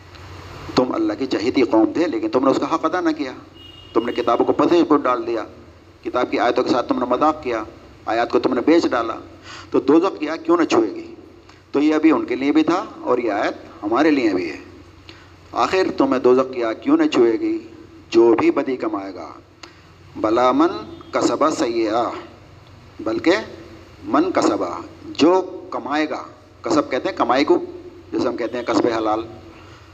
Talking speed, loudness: 190 wpm, -19 LUFS